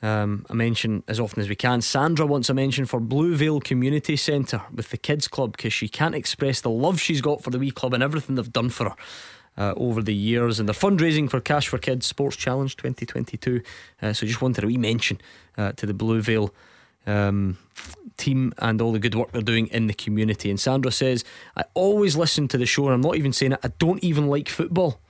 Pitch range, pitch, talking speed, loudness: 110-140 Hz, 125 Hz, 225 wpm, -23 LUFS